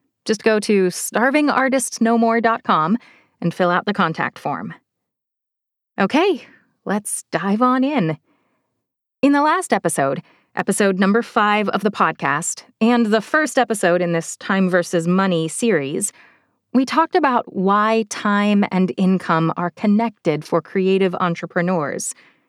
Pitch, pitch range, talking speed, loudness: 205 Hz, 180-235 Hz, 125 wpm, -18 LUFS